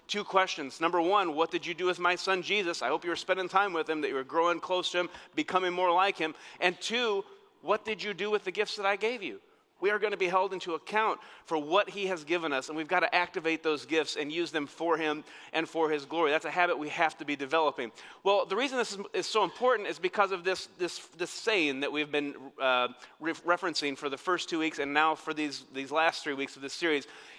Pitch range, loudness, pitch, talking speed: 155-195 Hz, -30 LUFS, 175 Hz, 260 wpm